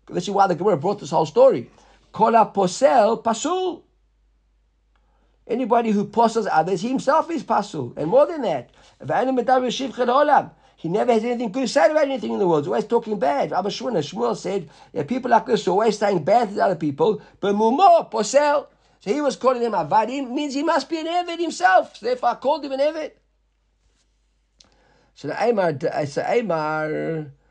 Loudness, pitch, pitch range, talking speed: -21 LUFS, 240 Hz, 210-290 Hz, 175 wpm